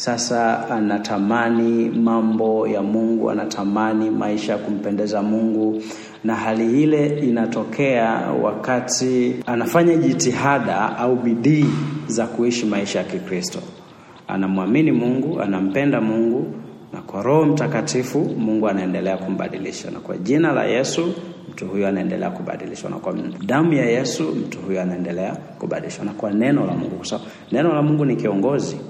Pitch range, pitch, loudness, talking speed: 105-125 Hz, 115 Hz, -20 LUFS, 135 wpm